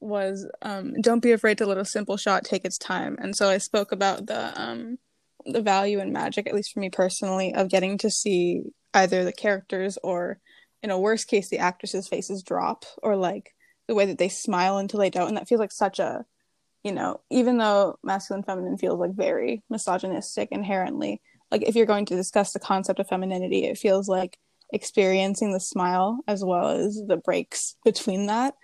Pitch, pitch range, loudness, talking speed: 195 Hz, 190-215 Hz, -25 LUFS, 200 wpm